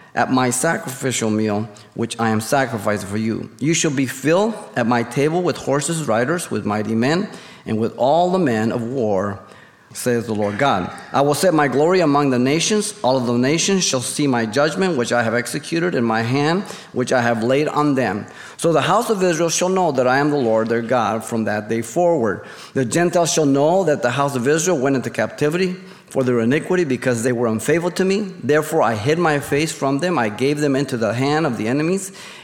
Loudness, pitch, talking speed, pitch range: -19 LUFS, 140 Hz, 220 wpm, 120-165 Hz